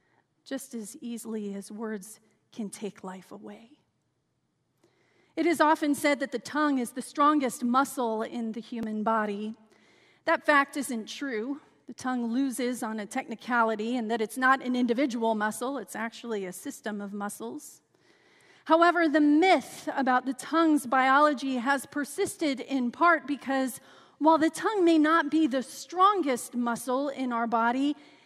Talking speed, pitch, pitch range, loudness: 150 wpm, 260 Hz, 230-295 Hz, -27 LUFS